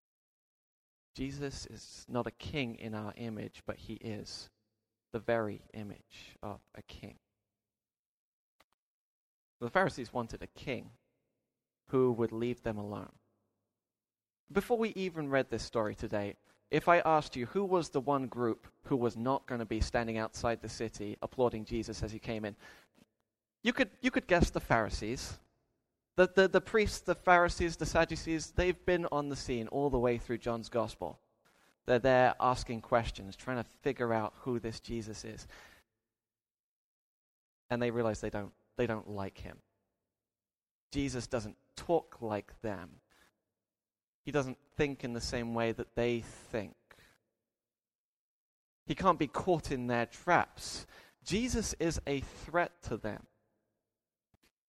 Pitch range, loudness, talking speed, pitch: 110-140 Hz, -34 LUFS, 145 wpm, 115 Hz